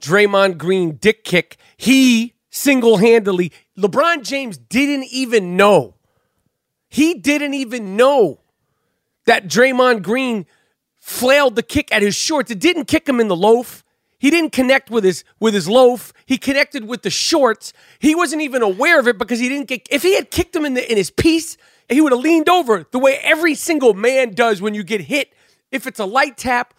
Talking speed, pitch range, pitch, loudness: 190 wpm, 220-285 Hz, 250 Hz, -15 LUFS